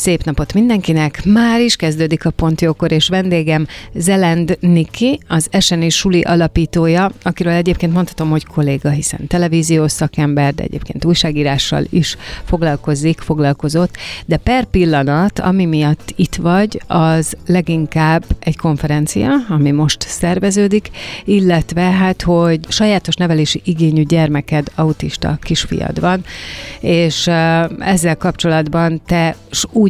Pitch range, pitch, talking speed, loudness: 155-180 Hz, 165 Hz, 120 wpm, -14 LUFS